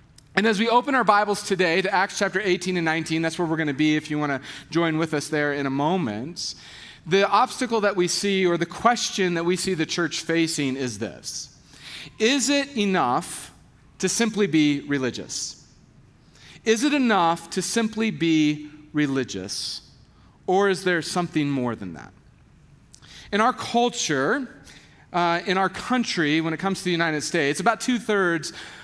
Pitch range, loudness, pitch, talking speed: 150-205 Hz, -23 LUFS, 175 Hz, 175 wpm